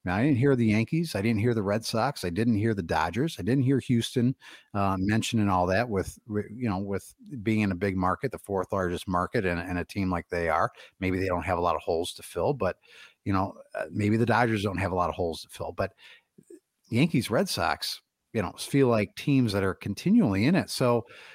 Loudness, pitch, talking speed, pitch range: -27 LUFS, 105 Hz, 235 wpm, 95-120 Hz